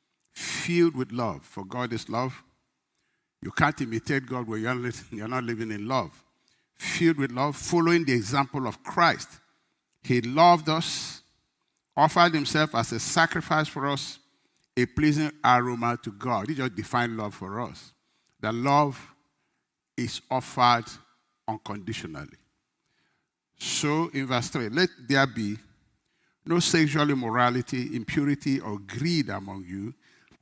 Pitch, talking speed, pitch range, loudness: 130 Hz, 130 wpm, 115-150 Hz, -26 LUFS